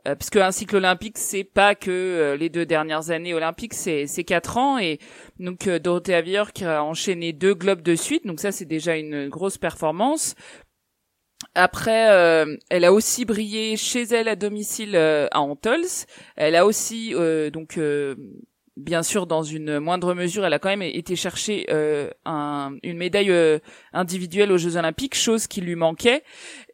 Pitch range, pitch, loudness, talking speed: 160-210 Hz, 180 Hz, -22 LUFS, 185 wpm